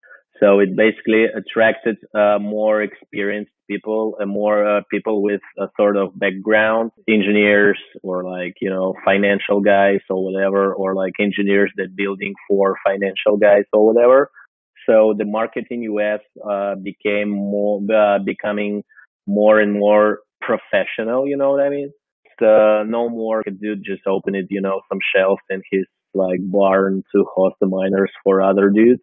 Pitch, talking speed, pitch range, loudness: 100 Hz, 160 wpm, 100-110 Hz, -17 LUFS